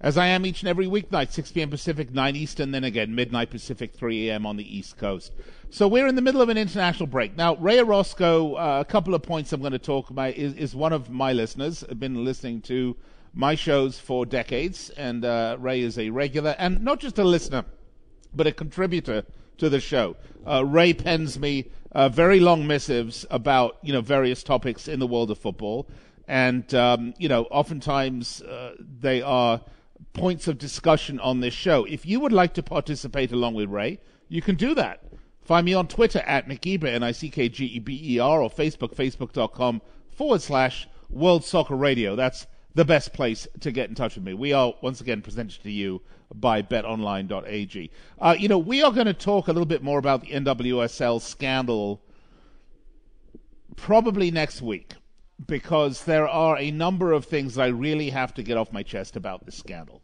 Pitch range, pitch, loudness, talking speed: 120-165 Hz, 140 Hz, -24 LUFS, 200 wpm